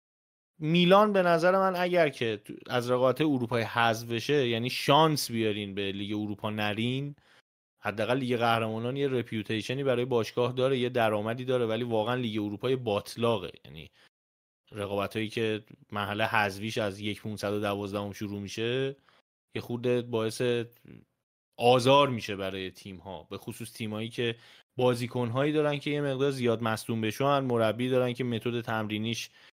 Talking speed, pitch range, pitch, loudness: 145 wpm, 105-125 Hz, 115 Hz, -29 LUFS